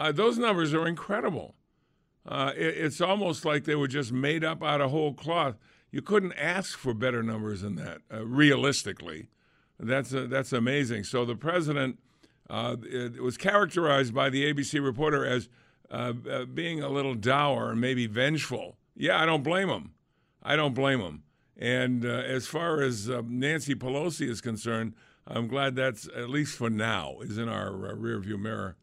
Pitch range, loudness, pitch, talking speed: 120-150 Hz, -29 LUFS, 135 Hz, 180 wpm